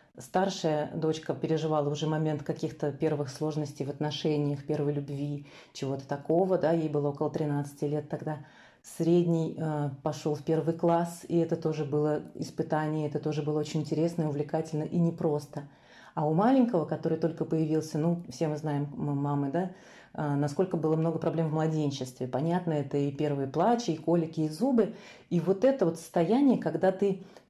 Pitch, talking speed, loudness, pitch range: 155 Hz, 165 wpm, -30 LUFS, 150-165 Hz